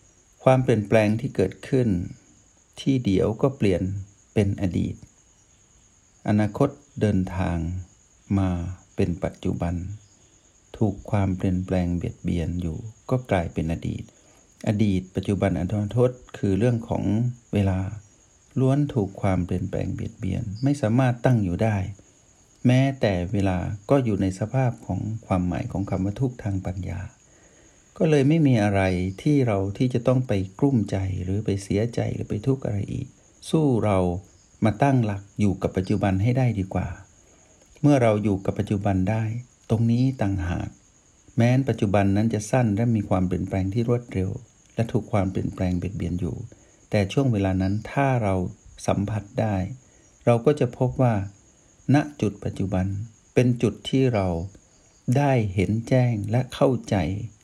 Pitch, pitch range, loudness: 105 Hz, 95-120 Hz, -24 LUFS